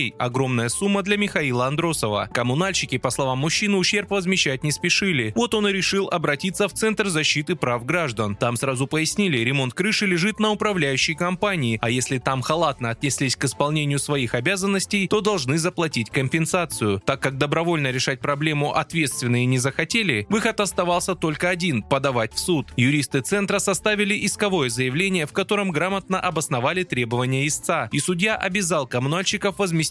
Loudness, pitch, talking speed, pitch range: -22 LUFS, 160 Hz, 155 wpm, 135-195 Hz